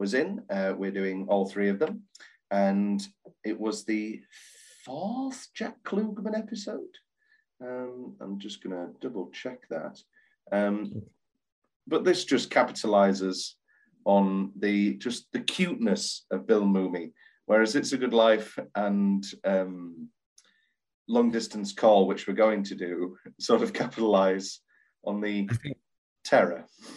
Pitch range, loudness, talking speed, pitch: 100-125 Hz, -28 LUFS, 130 wpm, 105 Hz